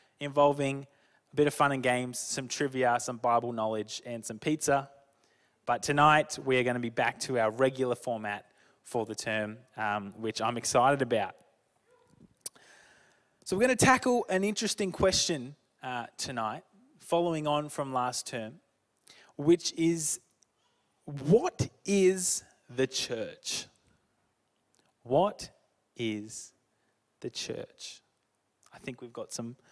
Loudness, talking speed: -30 LUFS, 130 wpm